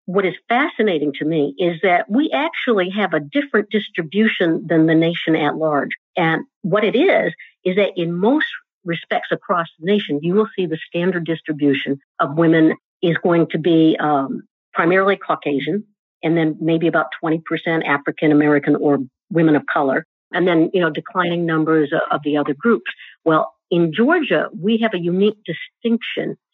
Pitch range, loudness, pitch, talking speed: 155-195 Hz, -18 LUFS, 170 Hz, 165 wpm